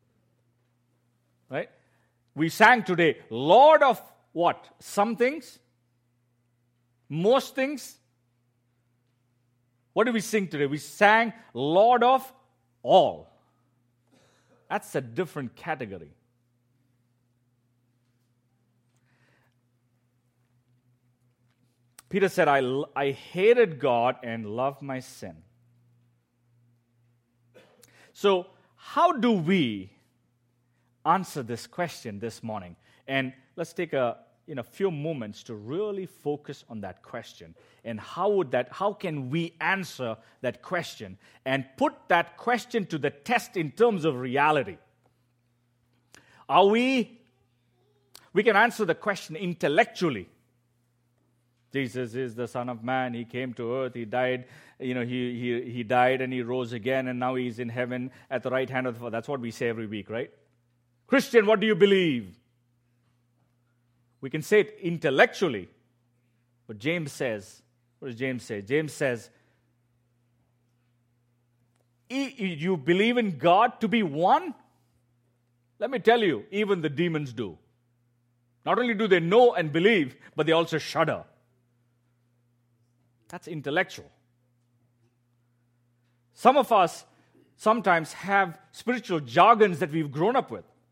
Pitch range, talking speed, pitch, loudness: 120-170 Hz, 125 wpm, 125 Hz, -26 LUFS